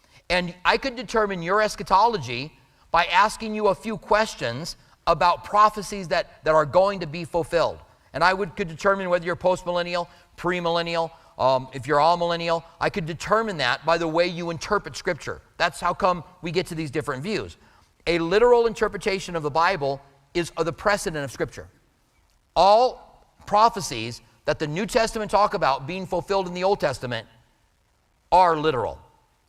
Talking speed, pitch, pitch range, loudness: 165 wpm, 175 Hz, 155-195 Hz, -23 LUFS